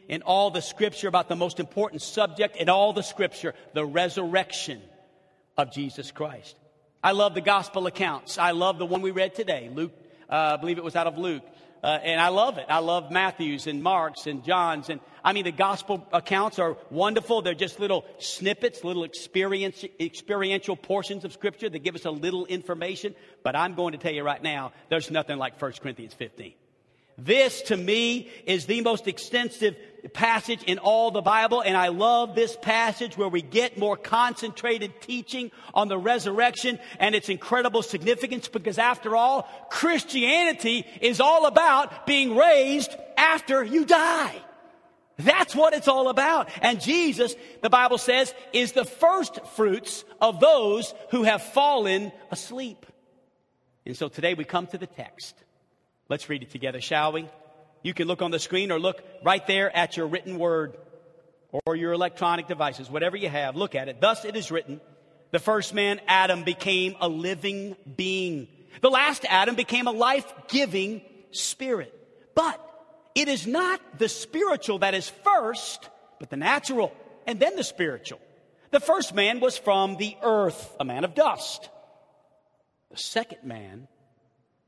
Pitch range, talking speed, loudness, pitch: 170-240 Hz, 170 wpm, -25 LUFS, 195 Hz